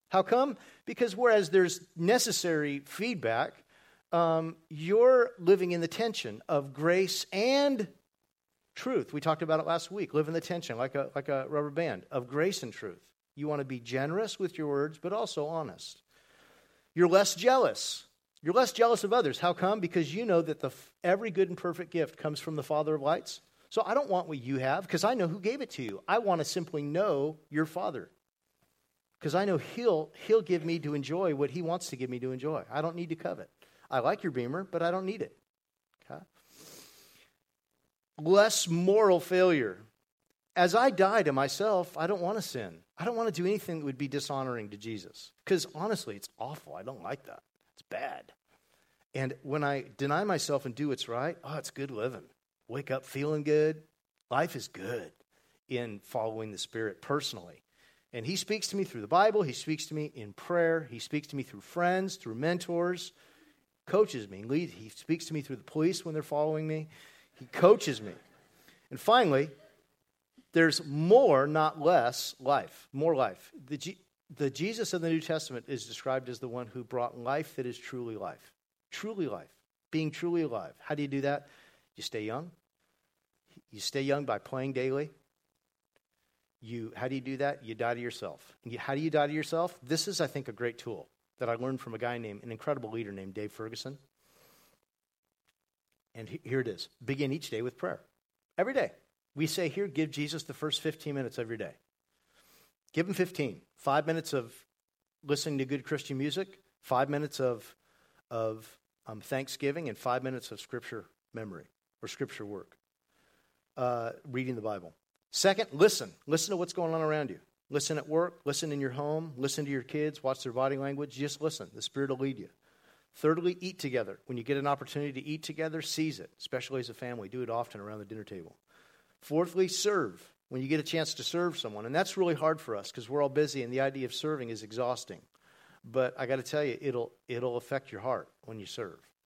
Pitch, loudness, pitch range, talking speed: 150 Hz, -32 LUFS, 130-175 Hz, 200 wpm